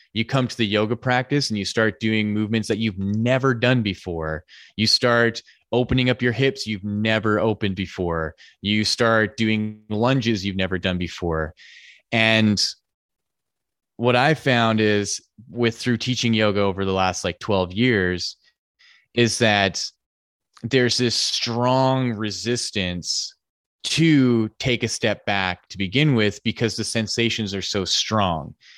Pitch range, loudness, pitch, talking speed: 100-120 Hz, -21 LUFS, 110 Hz, 145 wpm